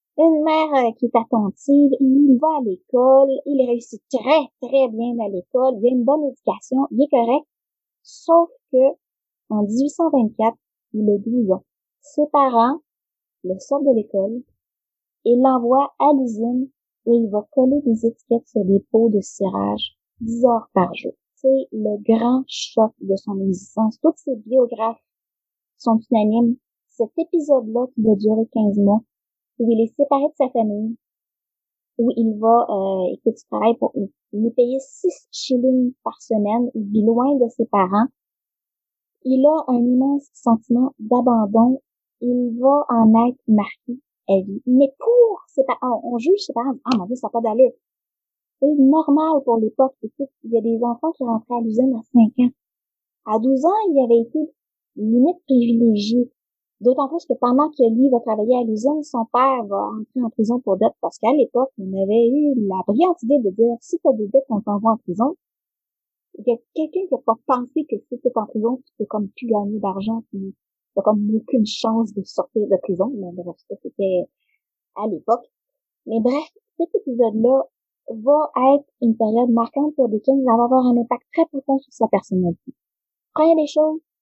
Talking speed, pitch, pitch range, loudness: 180 wpm, 245 Hz, 225-275 Hz, -19 LUFS